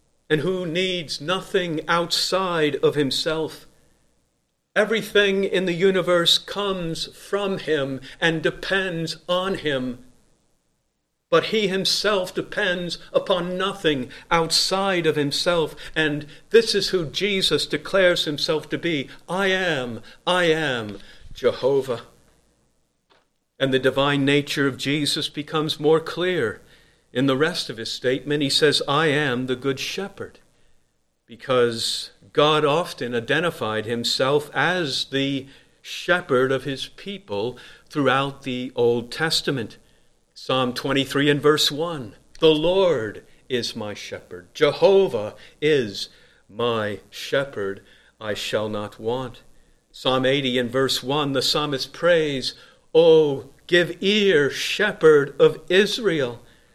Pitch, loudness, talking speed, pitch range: 155 Hz, -22 LUFS, 115 wpm, 135-180 Hz